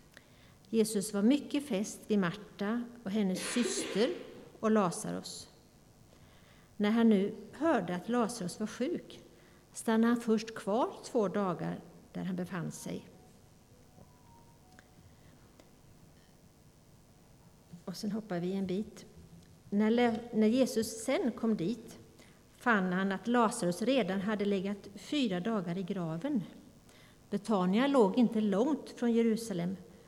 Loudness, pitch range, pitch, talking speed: -32 LUFS, 195-235 Hz, 215 Hz, 115 wpm